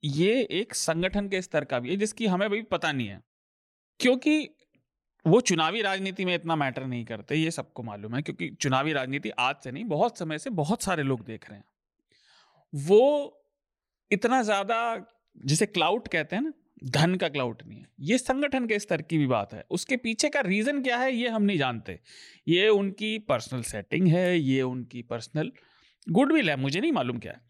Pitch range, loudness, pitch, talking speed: 140-225 Hz, -27 LUFS, 180 Hz, 190 wpm